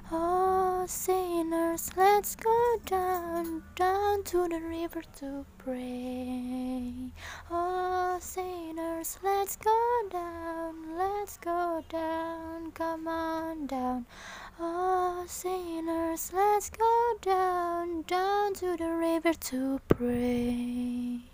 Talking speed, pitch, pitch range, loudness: 95 wpm, 335 Hz, 320-370 Hz, -31 LUFS